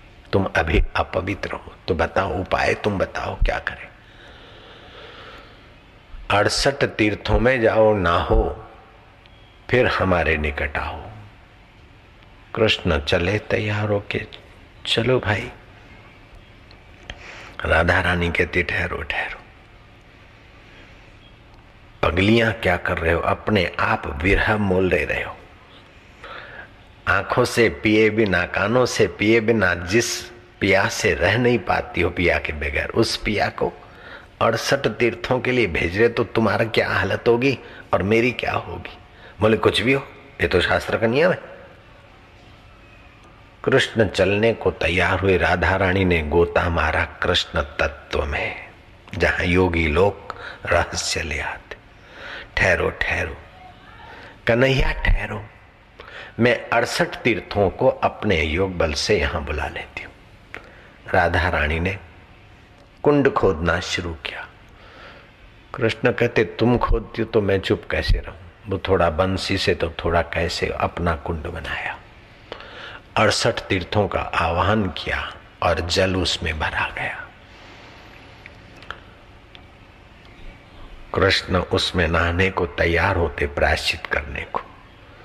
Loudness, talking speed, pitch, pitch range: -20 LUFS, 120 wpm, 95 Hz, 90-110 Hz